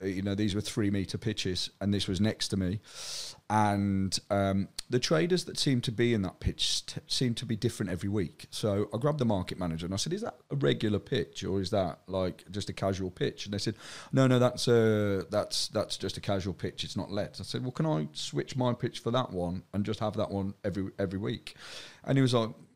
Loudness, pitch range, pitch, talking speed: -31 LUFS, 95-120 Hz, 105 Hz, 245 wpm